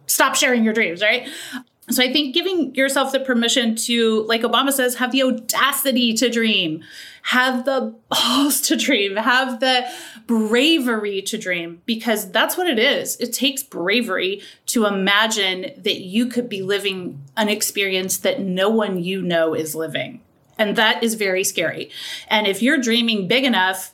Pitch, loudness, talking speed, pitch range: 230 Hz, -19 LUFS, 165 wpm, 200-260 Hz